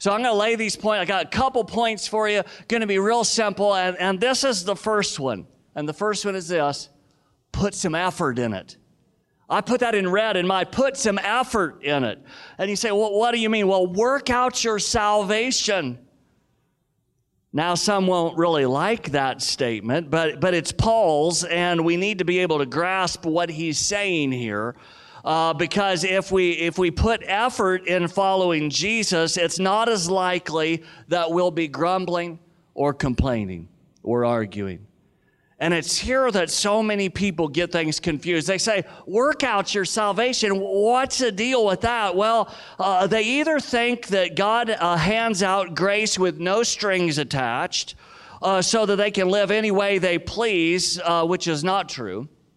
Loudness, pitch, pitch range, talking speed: -22 LUFS, 185 Hz, 165-215 Hz, 180 wpm